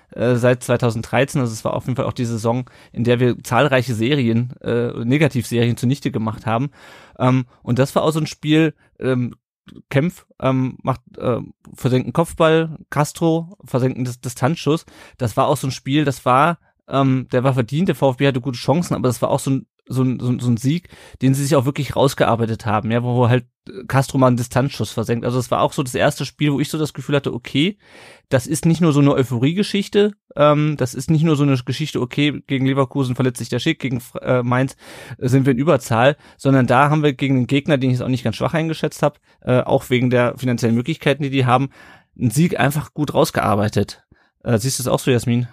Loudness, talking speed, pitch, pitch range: -19 LUFS, 220 wpm, 130 Hz, 125-150 Hz